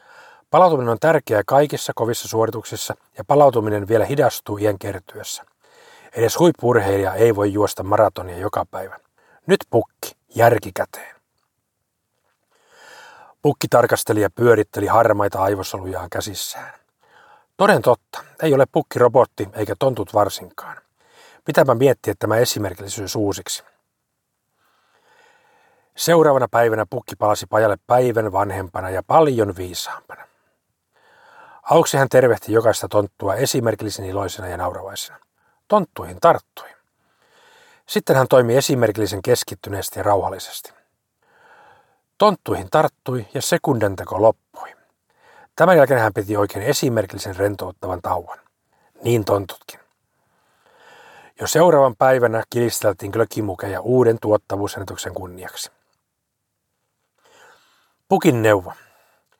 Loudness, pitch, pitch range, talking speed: -19 LUFS, 110 Hz, 100-140 Hz, 100 wpm